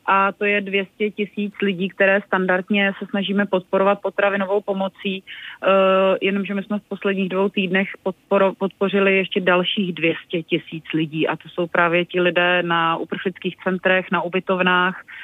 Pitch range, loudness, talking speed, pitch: 180-200 Hz, -20 LUFS, 150 wpm, 195 Hz